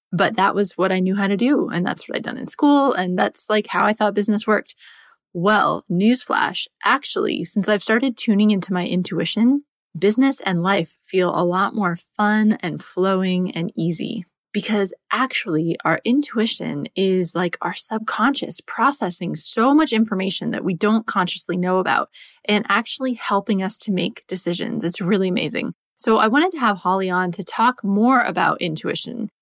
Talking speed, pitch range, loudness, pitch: 175 wpm, 185-225 Hz, -20 LUFS, 205 Hz